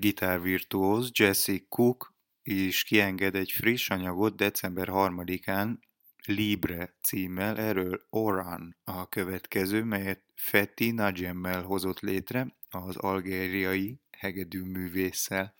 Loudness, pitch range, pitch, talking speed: -29 LUFS, 95-105 Hz, 95 Hz, 95 wpm